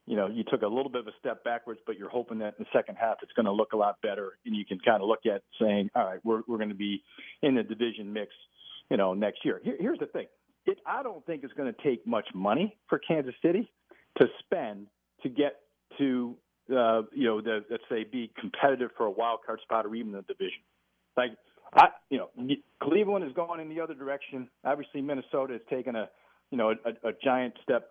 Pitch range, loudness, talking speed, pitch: 110-140 Hz, -30 LUFS, 235 wpm, 120 Hz